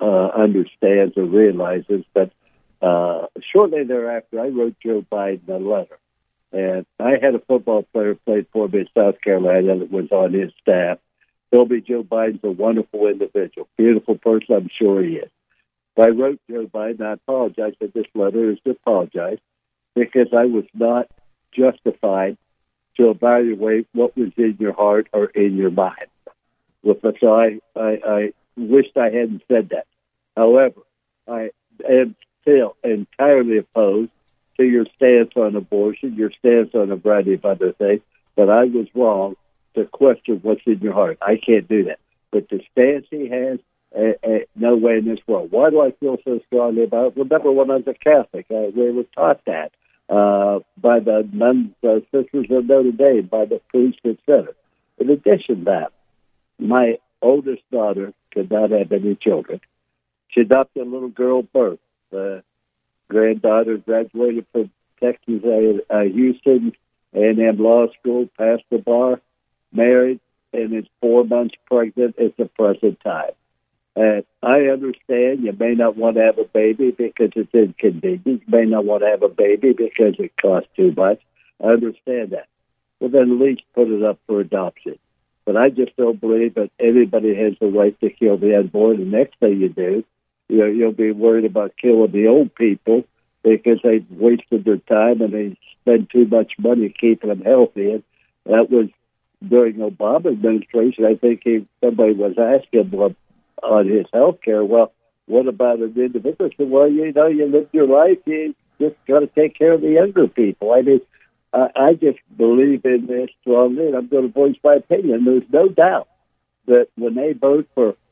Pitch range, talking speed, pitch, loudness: 110-125 Hz, 175 wpm, 115 Hz, -17 LUFS